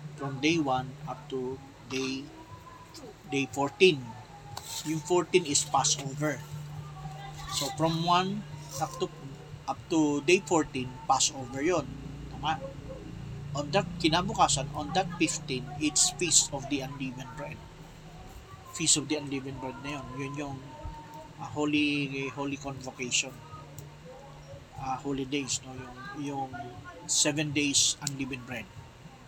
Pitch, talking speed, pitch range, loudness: 145 Hz, 125 wpm, 135-155 Hz, -29 LUFS